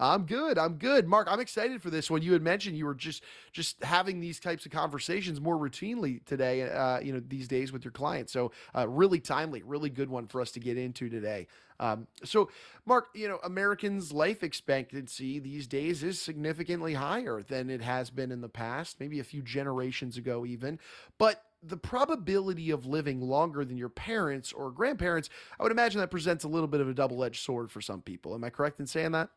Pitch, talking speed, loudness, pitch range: 145 Hz, 215 wpm, -32 LUFS, 130-175 Hz